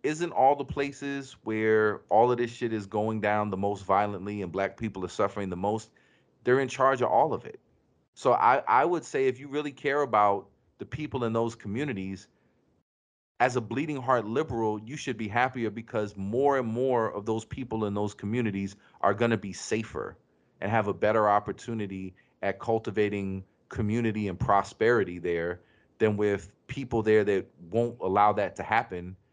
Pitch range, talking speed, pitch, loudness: 100-125 Hz, 180 wpm, 110 Hz, -28 LUFS